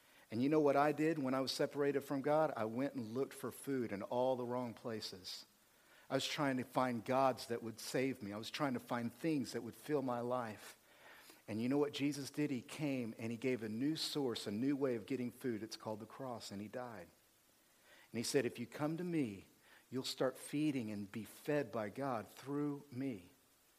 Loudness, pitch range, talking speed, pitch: -40 LUFS, 115-140 Hz, 225 wpm, 130 Hz